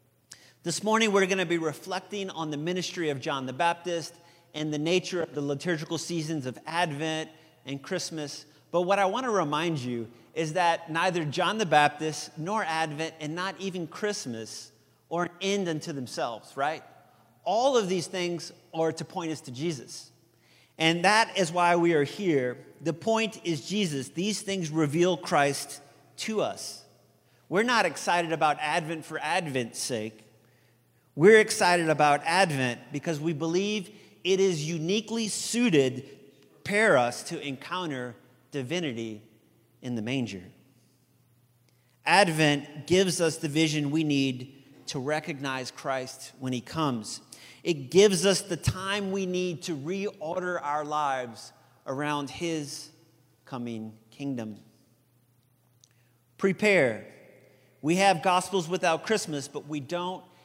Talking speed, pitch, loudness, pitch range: 140 wpm, 160 Hz, -28 LUFS, 135-180 Hz